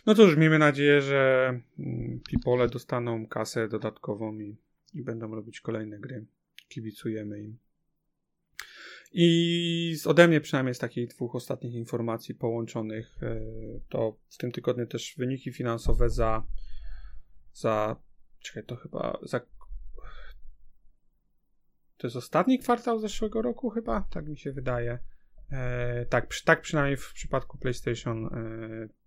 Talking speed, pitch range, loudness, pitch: 125 wpm, 110-145 Hz, -28 LUFS, 120 Hz